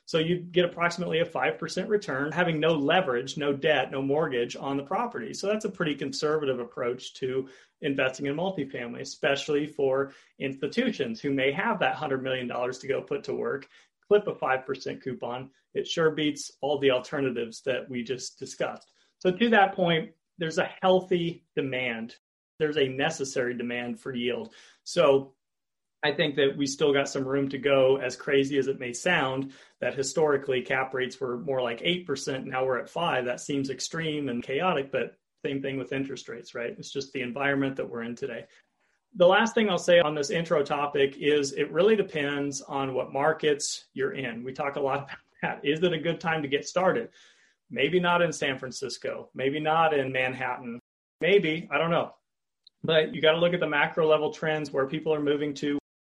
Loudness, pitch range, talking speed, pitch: -27 LUFS, 130-165 Hz, 190 wpm, 145 Hz